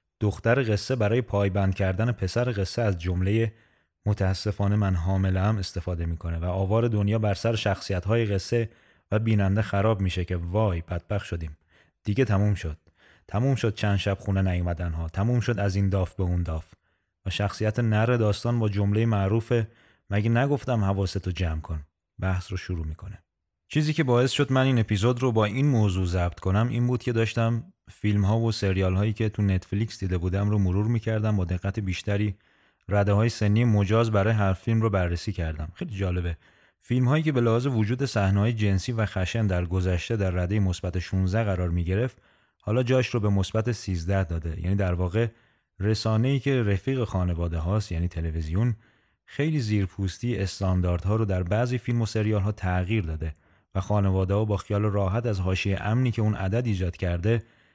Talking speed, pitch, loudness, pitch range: 180 wpm, 100 Hz, -26 LUFS, 95-115 Hz